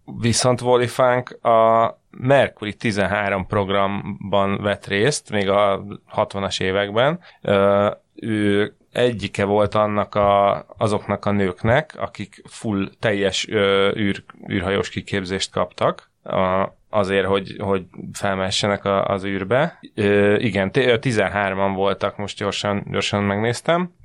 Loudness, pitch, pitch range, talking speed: -20 LUFS, 100 Hz, 100-110 Hz, 115 wpm